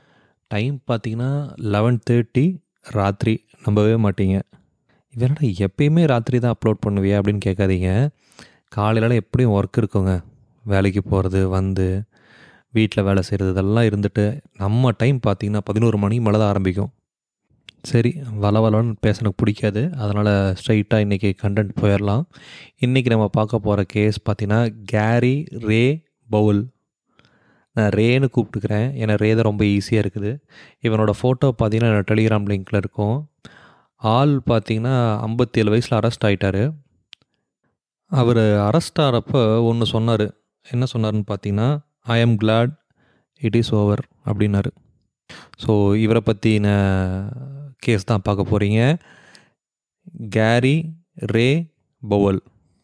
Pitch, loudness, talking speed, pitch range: 110 Hz, -19 LUFS, 115 wpm, 105-125 Hz